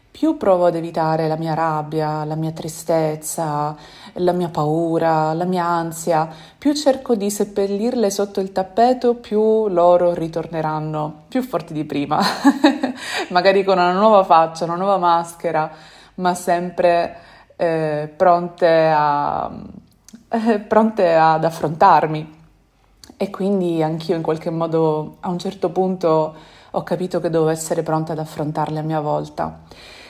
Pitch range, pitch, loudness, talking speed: 155-195 Hz, 170 Hz, -19 LUFS, 135 wpm